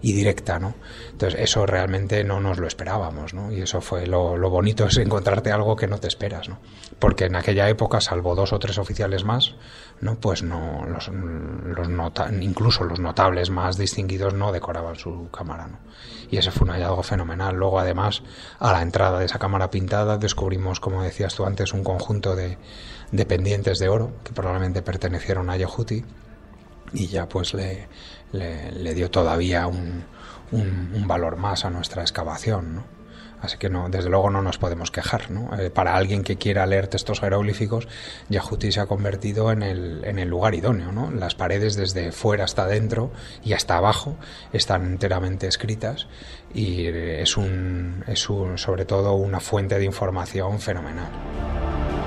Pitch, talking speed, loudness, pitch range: 95 Hz, 175 wpm, -24 LUFS, 90-105 Hz